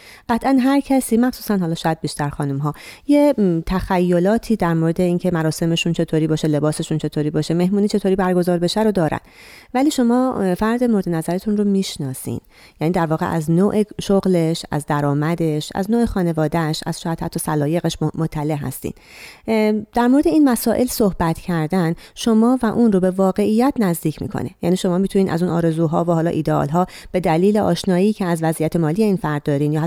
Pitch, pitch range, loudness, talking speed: 175 Hz, 160-210 Hz, -19 LUFS, 170 wpm